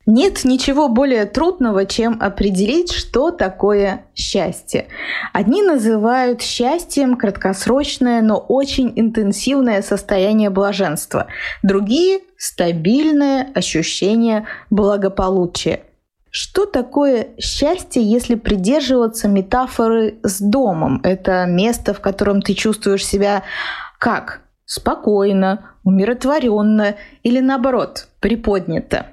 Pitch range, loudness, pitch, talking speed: 200-260 Hz, -16 LUFS, 220 Hz, 90 wpm